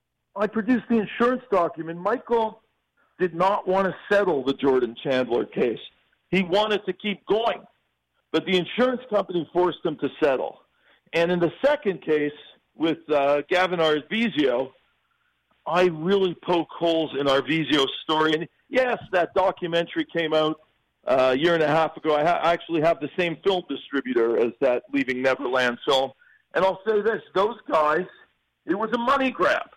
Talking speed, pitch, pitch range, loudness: 165 wpm, 170 Hz, 150-200 Hz, -24 LUFS